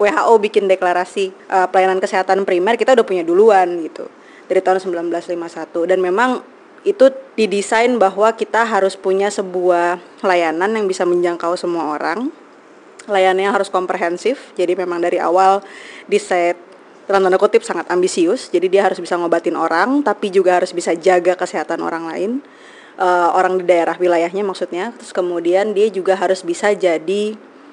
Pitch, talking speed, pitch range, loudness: 190 Hz, 155 wpm, 180-210 Hz, -16 LUFS